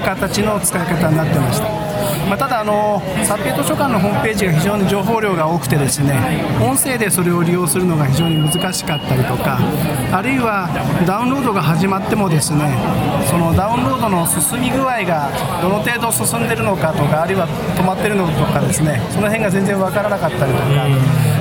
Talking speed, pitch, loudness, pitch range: 410 characters per minute, 175 Hz, -16 LUFS, 150-200 Hz